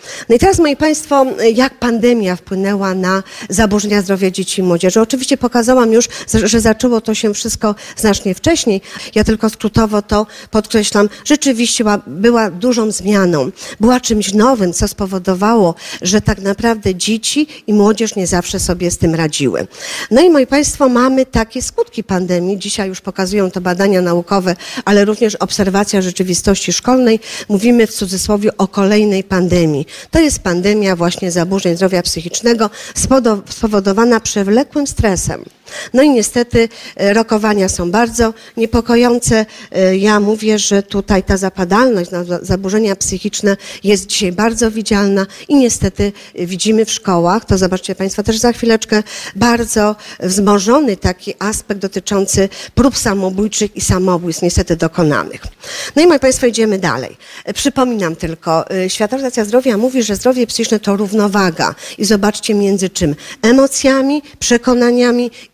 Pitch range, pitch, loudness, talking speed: 190-235 Hz, 210 Hz, -13 LUFS, 135 wpm